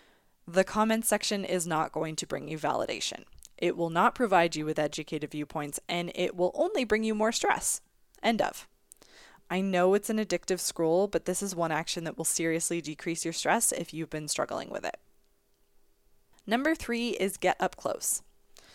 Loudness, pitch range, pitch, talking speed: -29 LUFS, 155-195 Hz, 170 Hz, 180 wpm